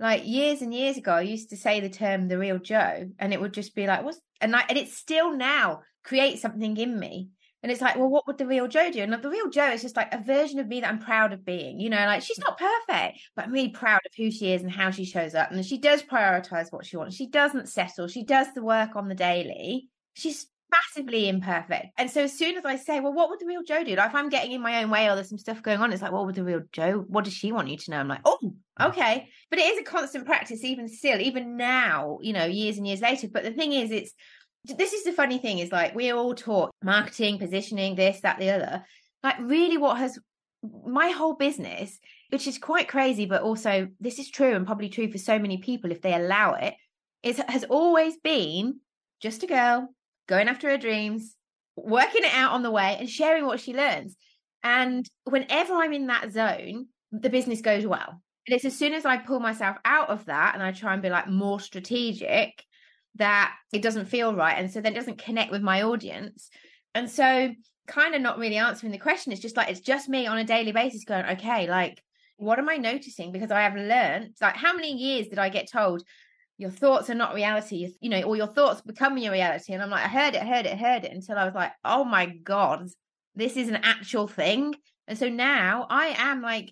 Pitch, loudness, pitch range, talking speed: 230 Hz, -25 LUFS, 200-270 Hz, 245 wpm